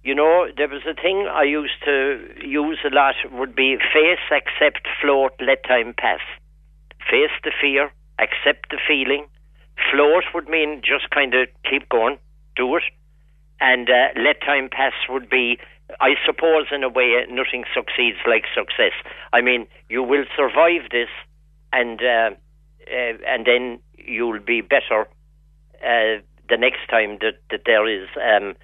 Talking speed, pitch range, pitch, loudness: 155 wpm, 125-150 Hz, 140 Hz, -19 LUFS